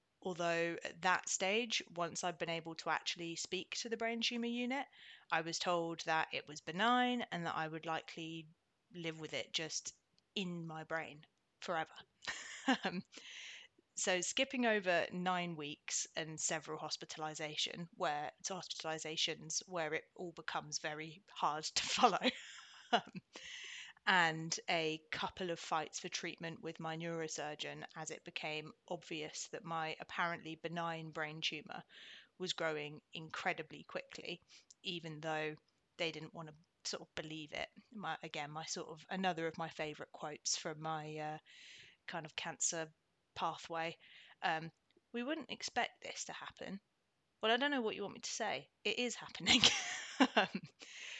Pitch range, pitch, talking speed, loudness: 160-190 Hz, 165 Hz, 150 wpm, -40 LUFS